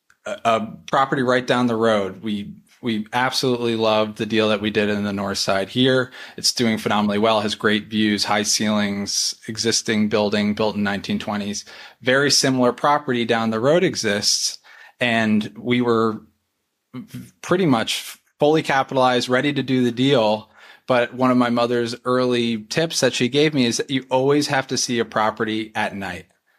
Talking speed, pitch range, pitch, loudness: 170 wpm, 105-125 Hz, 115 Hz, -20 LUFS